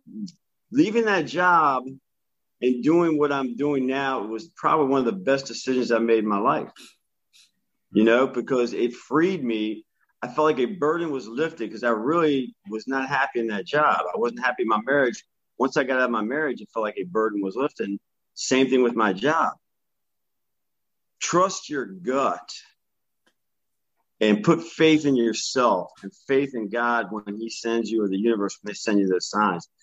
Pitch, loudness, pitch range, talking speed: 125 Hz, -23 LUFS, 110-140 Hz, 185 wpm